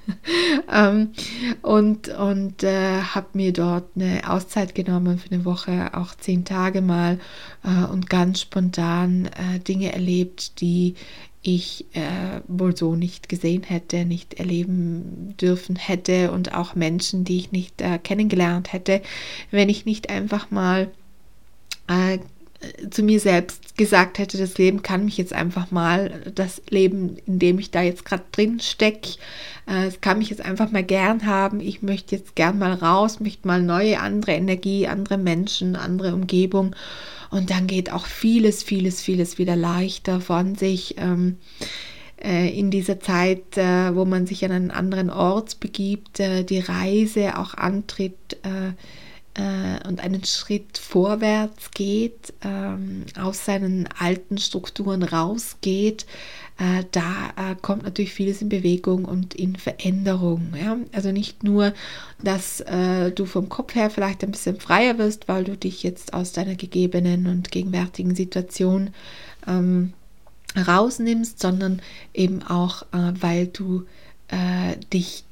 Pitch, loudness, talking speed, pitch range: 185 Hz, -22 LUFS, 145 wpm, 180-200 Hz